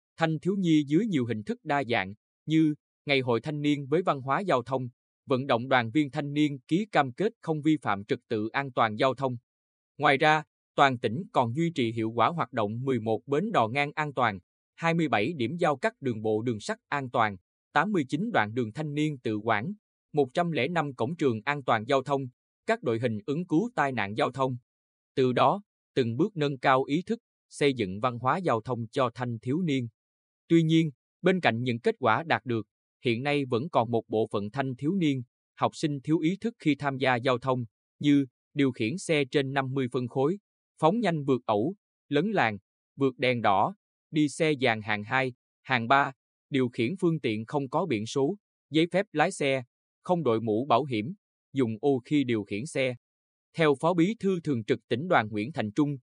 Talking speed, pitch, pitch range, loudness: 205 wpm, 135 Hz, 115-155 Hz, -28 LUFS